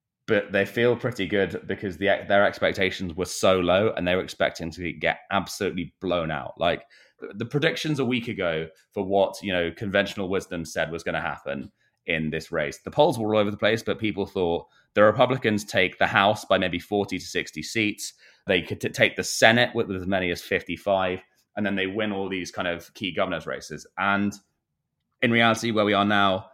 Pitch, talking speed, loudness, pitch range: 100 Hz, 205 wpm, -24 LUFS, 95-110 Hz